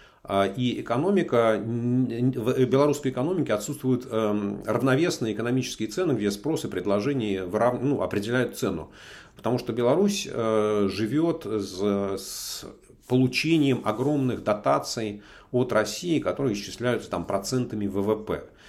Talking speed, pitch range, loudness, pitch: 105 wpm, 105-130 Hz, -26 LUFS, 120 Hz